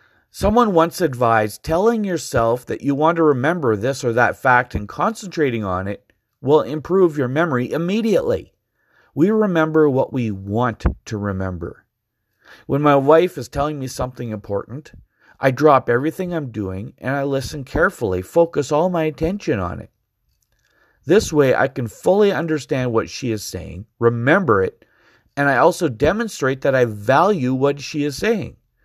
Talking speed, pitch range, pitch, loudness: 160 wpm, 115-165 Hz, 140 Hz, -19 LUFS